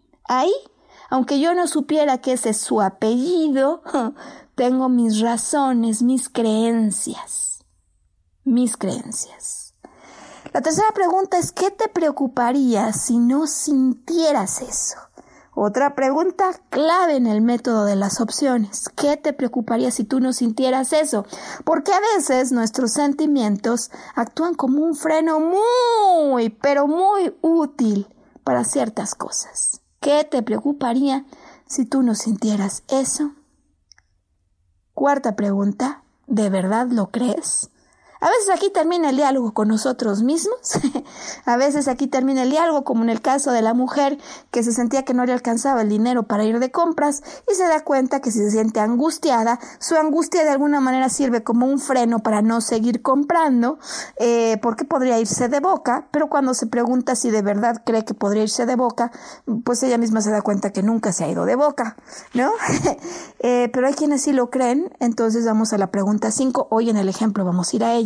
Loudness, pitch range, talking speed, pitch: -20 LUFS, 230-295 Hz, 165 wpm, 255 Hz